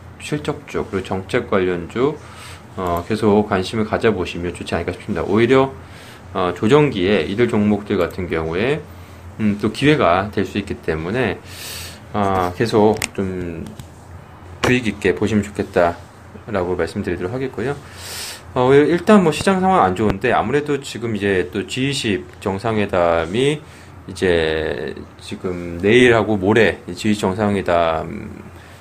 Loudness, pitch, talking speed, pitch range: -18 LUFS, 100 Hz, 270 characters per minute, 90-115 Hz